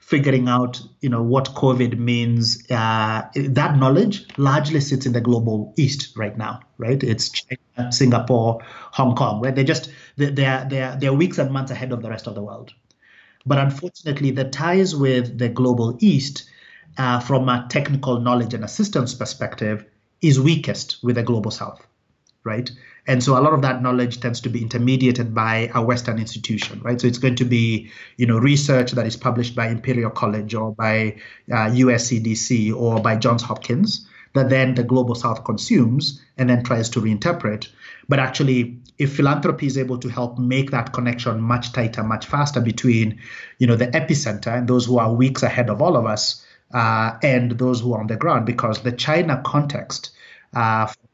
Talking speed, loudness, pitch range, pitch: 185 wpm, -20 LUFS, 115-135 Hz, 125 Hz